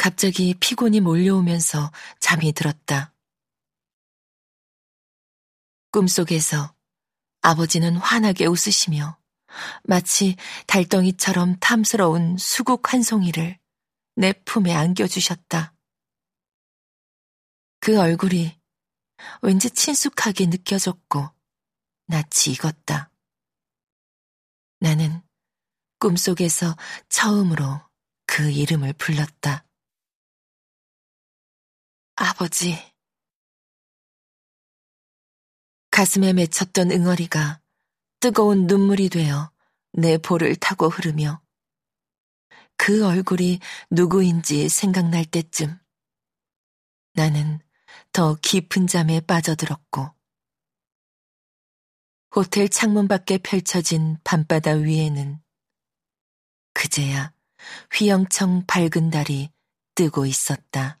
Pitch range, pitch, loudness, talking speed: 155-190 Hz, 170 Hz, -20 LUFS, 170 characters per minute